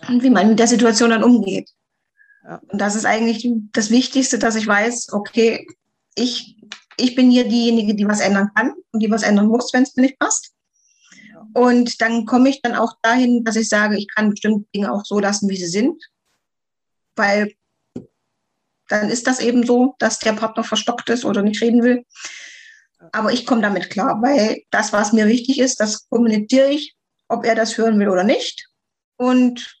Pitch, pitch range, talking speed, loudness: 230 Hz, 215-250 Hz, 190 wpm, -17 LUFS